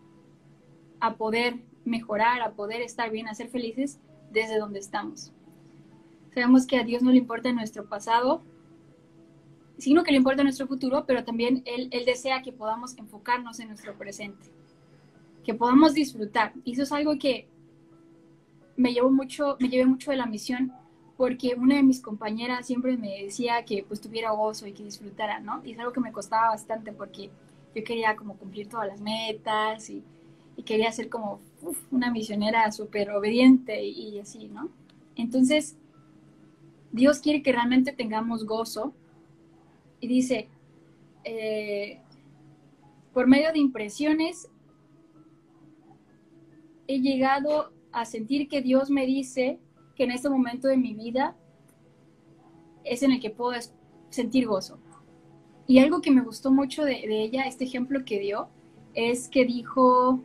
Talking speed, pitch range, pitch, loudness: 150 wpm, 205-260 Hz, 230 Hz, -26 LUFS